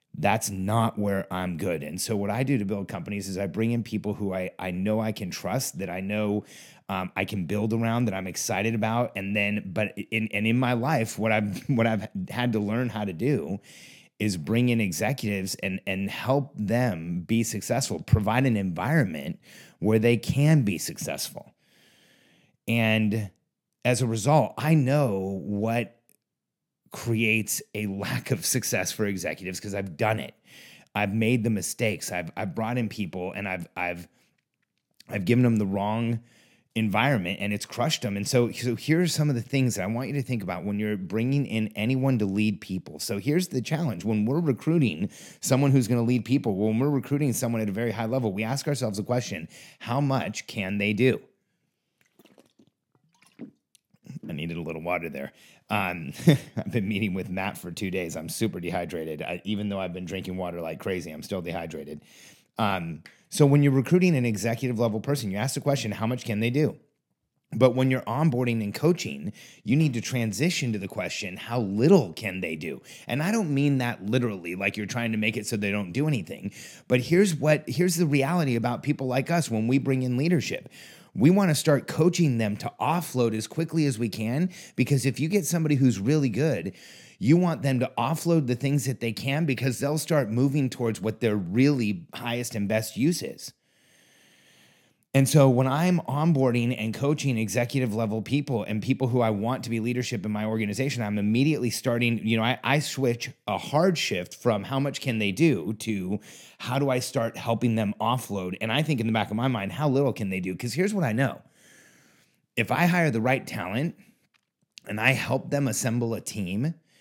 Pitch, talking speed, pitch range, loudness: 115 Hz, 200 wpm, 105-135 Hz, -26 LUFS